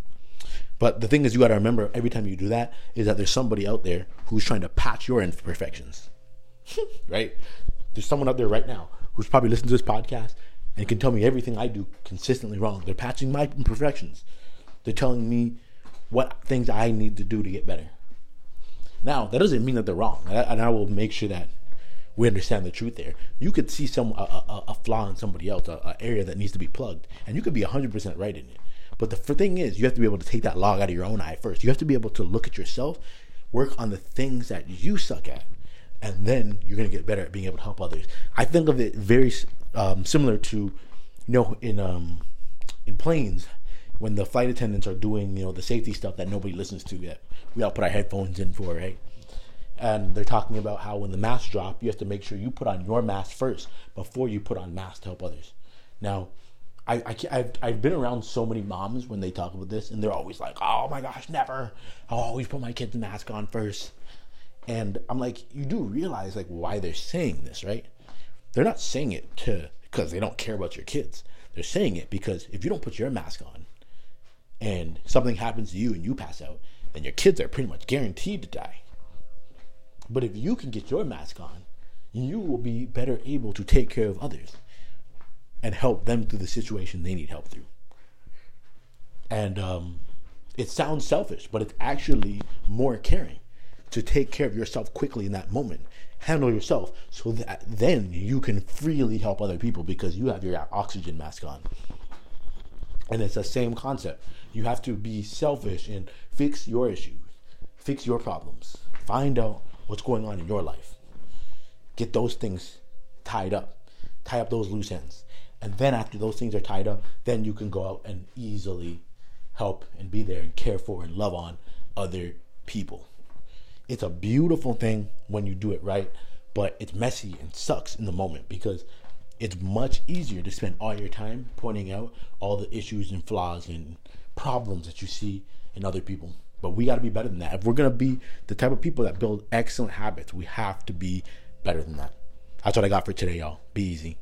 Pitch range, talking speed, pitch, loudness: 95-120 Hz, 215 wpm, 105 Hz, -28 LUFS